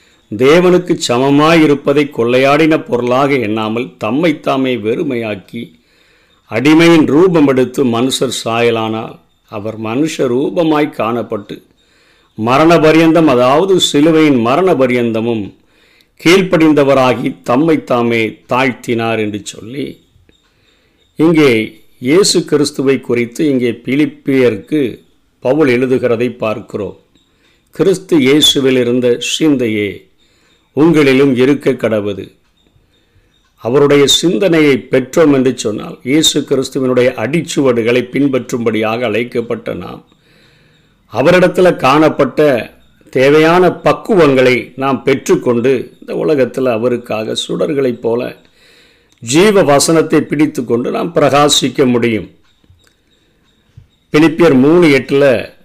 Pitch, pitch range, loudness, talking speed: 130 Hz, 115-150 Hz, -11 LUFS, 80 wpm